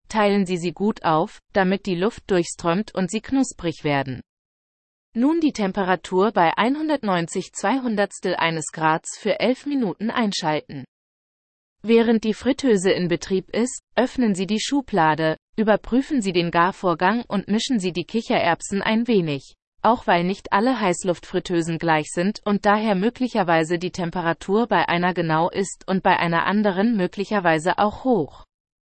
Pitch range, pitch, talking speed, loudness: 170-220 Hz, 195 Hz, 140 wpm, -22 LUFS